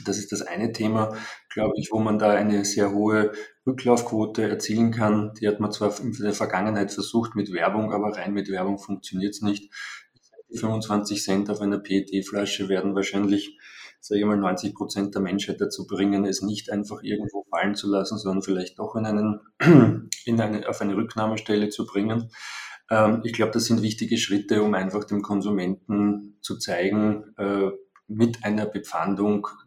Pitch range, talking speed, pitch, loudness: 100-110 Hz, 170 wpm, 105 Hz, -24 LUFS